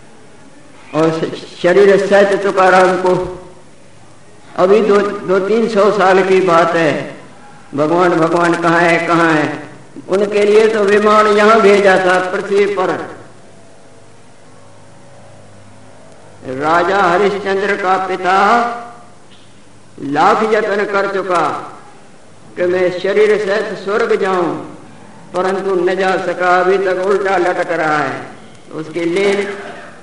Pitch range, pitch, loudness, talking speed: 165-200 Hz, 185 Hz, -13 LUFS, 110 wpm